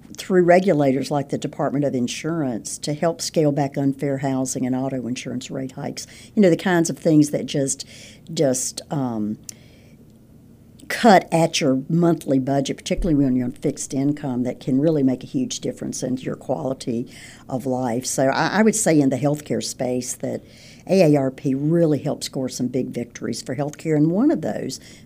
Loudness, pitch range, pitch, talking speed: -21 LUFS, 130-155 Hz, 135 Hz, 175 wpm